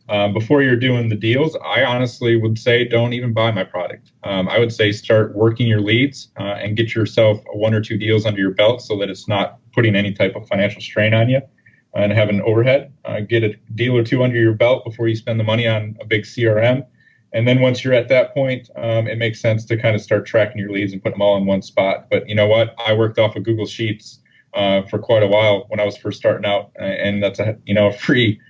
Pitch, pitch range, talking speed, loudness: 110 Hz, 105-120 Hz, 255 wpm, -17 LUFS